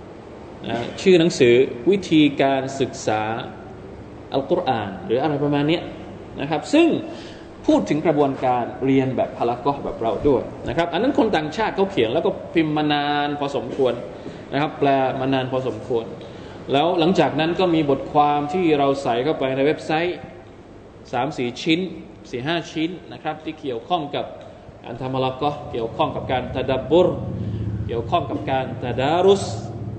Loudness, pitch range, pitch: -21 LUFS, 125-160 Hz, 140 Hz